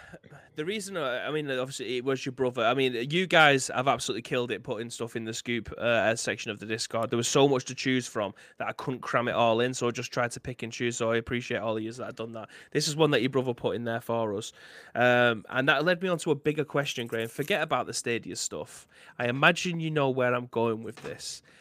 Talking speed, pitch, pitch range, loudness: 265 wpm, 125 Hz, 115-145 Hz, -28 LUFS